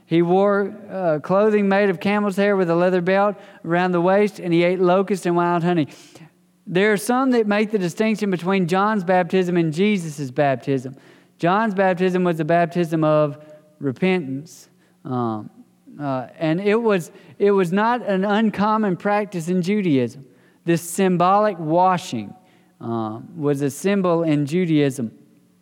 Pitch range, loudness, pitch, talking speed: 160-200 Hz, -20 LUFS, 180 Hz, 150 wpm